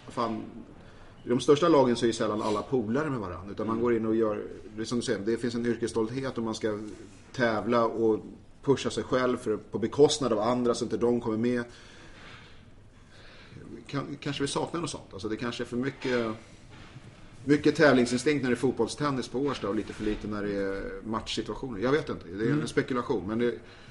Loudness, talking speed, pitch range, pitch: -29 LUFS, 205 wpm, 110-125 Hz, 115 Hz